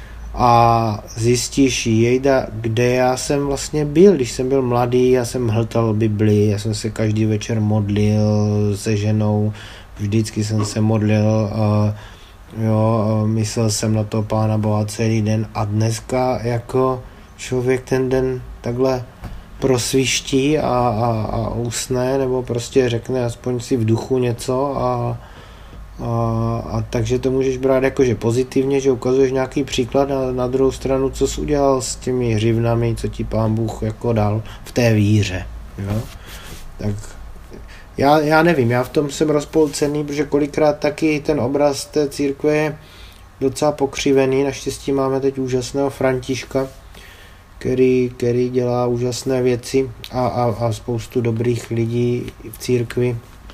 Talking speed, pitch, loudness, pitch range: 145 wpm, 120 Hz, -18 LUFS, 110-130 Hz